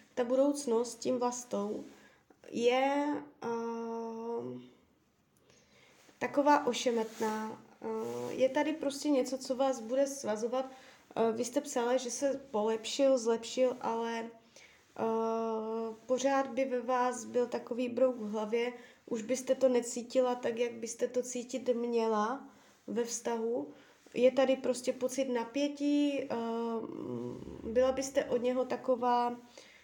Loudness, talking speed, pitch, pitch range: -33 LUFS, 120 wpm, 245 Hz, 230-260 Hz